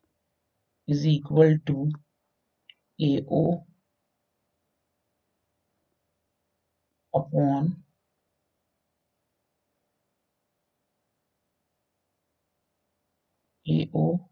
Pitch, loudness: 100 Hz, -25 LUFS